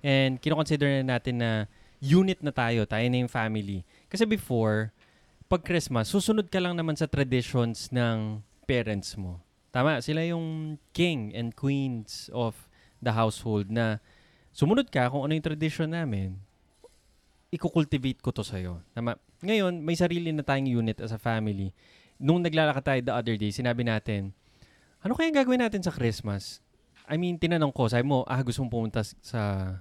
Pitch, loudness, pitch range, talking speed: 125 Hz, -28 LUFS, 110-155 Hz, 165 wpm